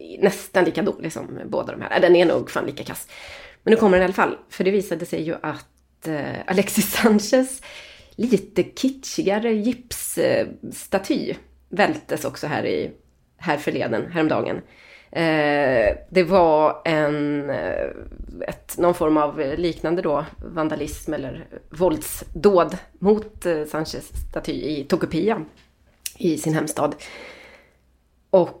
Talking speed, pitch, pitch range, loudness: 120 wpm, 175 Hz, 150-200 Hz, -22 LUFS